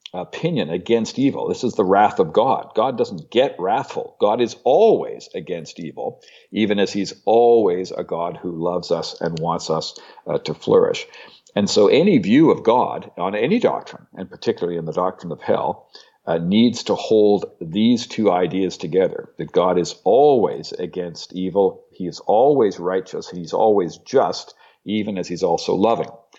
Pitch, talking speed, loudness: 120 Hz, 170 wpm, -19 LUFS